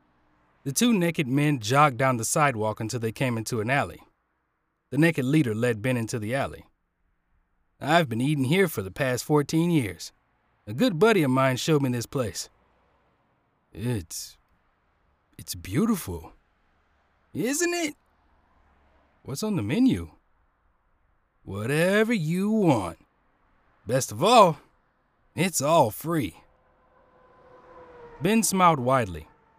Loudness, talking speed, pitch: -24 LUFS, 125 wpm, 125 Hz